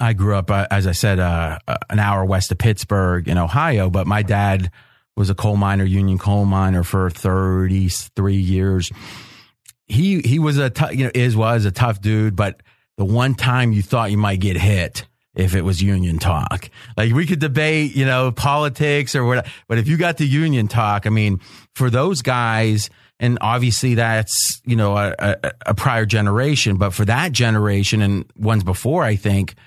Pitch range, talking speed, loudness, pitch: 95-125 Hz, 190 wpm, -18 LUFS, 105 Hz